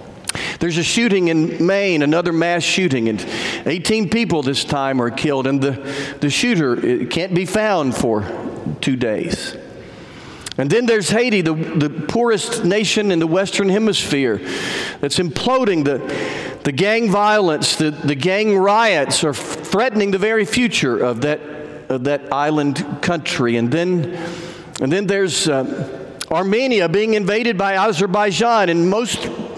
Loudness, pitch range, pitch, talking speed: -17 LUFS, 150-210 Hz, 175 Hz, 155 wpm